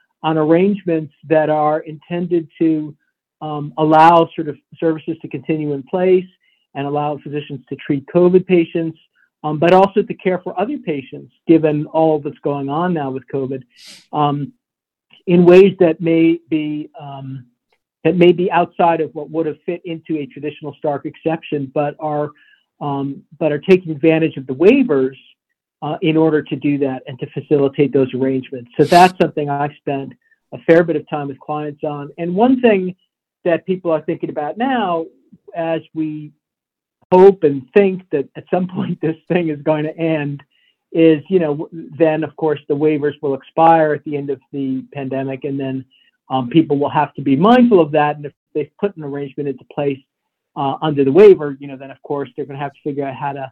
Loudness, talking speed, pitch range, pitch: -16 LUFS, 190 wpm, 145-165 Hz, 155 Hz